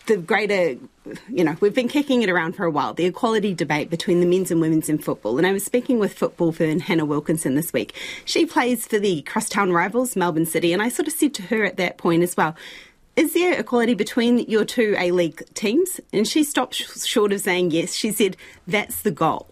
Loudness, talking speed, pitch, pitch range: -21 LUFS, 225 wpm, 195 Hz, 170-235 Hz